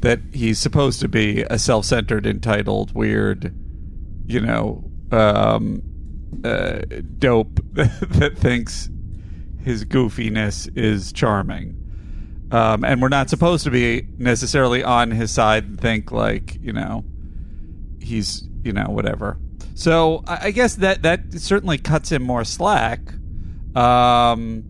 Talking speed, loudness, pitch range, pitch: 125 wpm, -19 LUFS, 90-125 Hz, 110 Hz